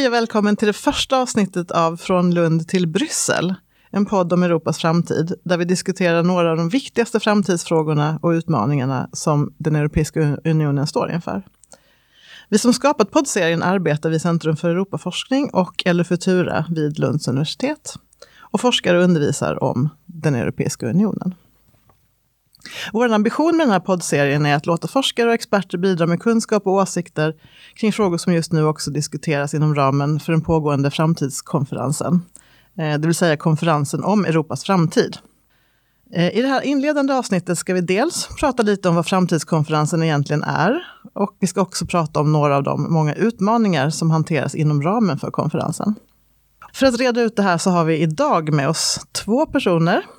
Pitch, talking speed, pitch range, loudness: 170 Hz, 165 wpm, 155-200 Hz, -19 LUFS